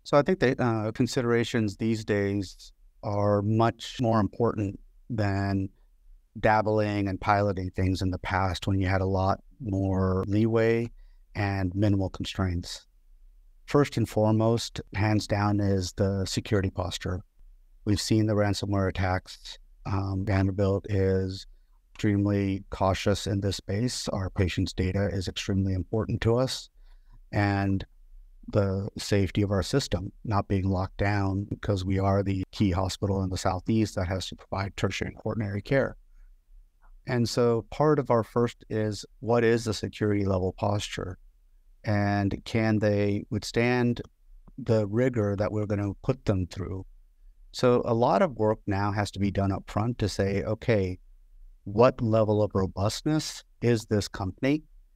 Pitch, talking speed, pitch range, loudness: 100 Hz, 145 wpm, 95-110 Hz, -27 LUFS